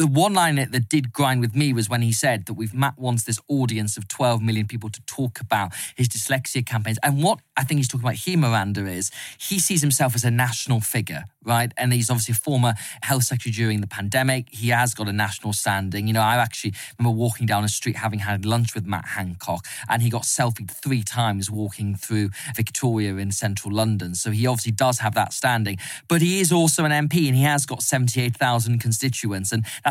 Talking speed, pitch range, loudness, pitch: 220 wpm, 110-130 Hz, -22 LUFS, 120 Hz